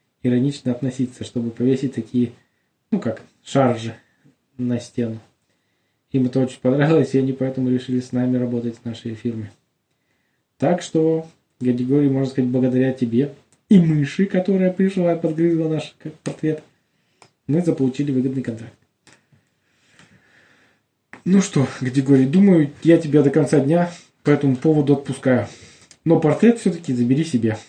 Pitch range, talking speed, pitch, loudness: 125-155 Hz, 130 wpm, 135 Hz, -20 LUFS